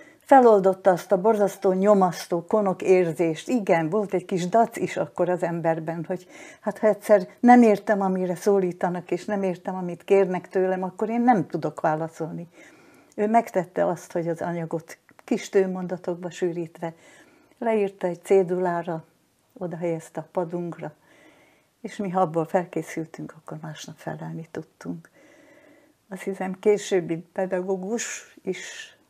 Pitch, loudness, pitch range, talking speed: 185 Hz, -24 LUFS, 175-215 Hz, 130 wpm